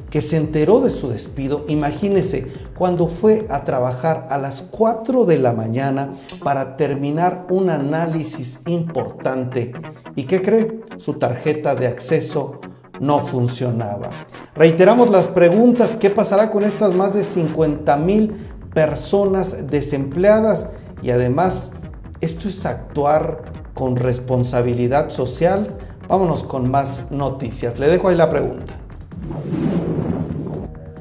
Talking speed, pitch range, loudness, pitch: 120 wpm, 130-185 Hz, -18 LUFS, 150 Hz